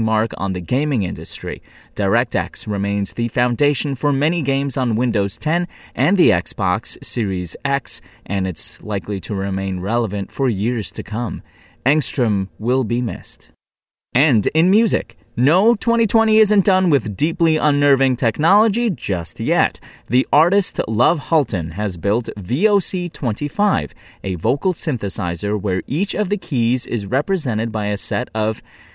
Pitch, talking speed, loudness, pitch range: 120 Hz, 140 wpm, -19 LUFS, 105-155 Hz